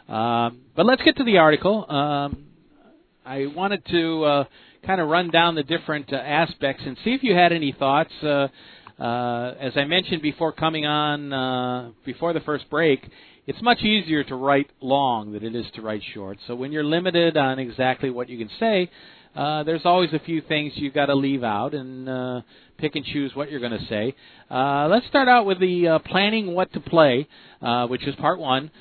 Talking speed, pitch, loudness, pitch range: 205 wpm, 145 Hz, -22 LUFS, 130-170 Hz